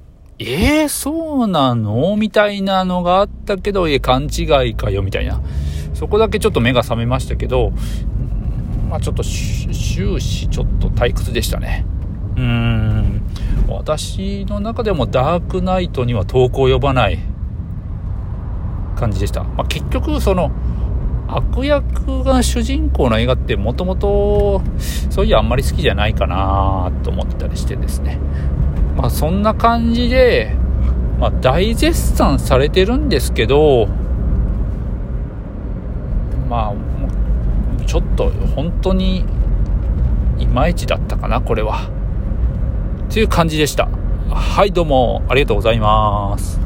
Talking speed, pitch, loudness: 260 characters per minute, 95 Hz, -17 LUFS